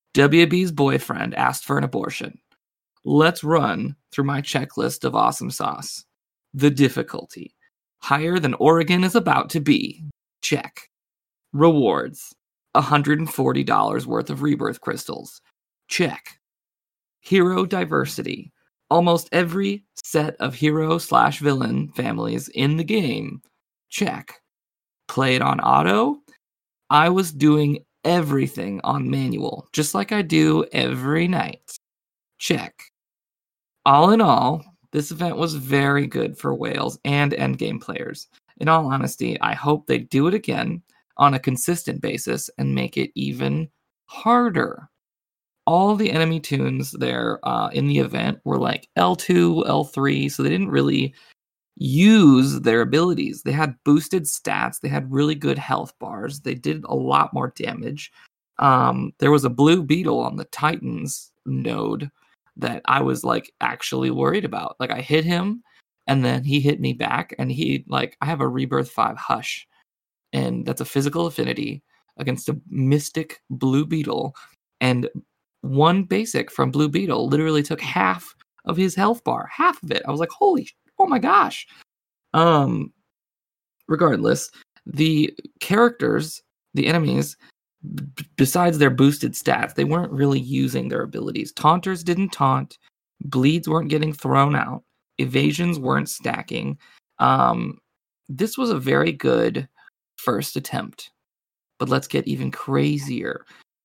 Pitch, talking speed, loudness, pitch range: 150 Hz, 140 wpm, -21 LUFS, 135-170 Hz